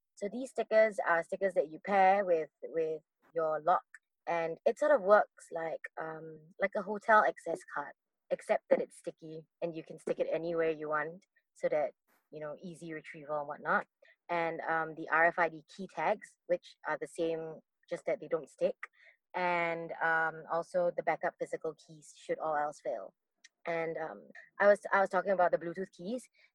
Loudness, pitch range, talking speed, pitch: -33 LUFS, 160-205 Hz, 185 wpm, 170 Hz